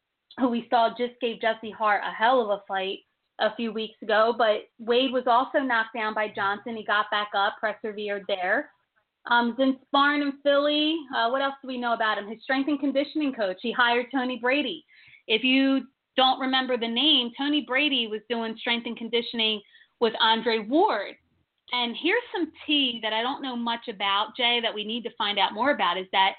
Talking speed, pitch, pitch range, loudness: 200 wpm, 235 Hz, 220-265 Hz, -25 LUFS